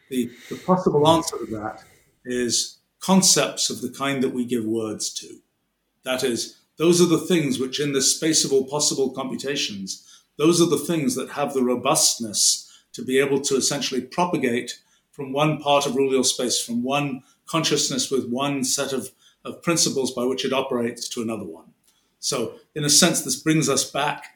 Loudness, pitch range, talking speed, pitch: -21 LUFS, 125-150 Hz, 180 wpm, 135 Hz